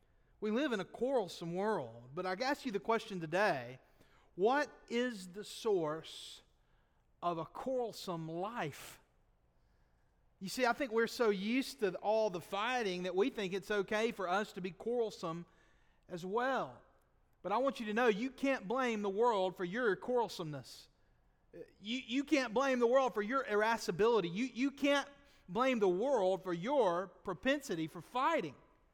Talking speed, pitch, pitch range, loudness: 160 wpm, 215 Hz, 185-255 Hz, -36 LUFS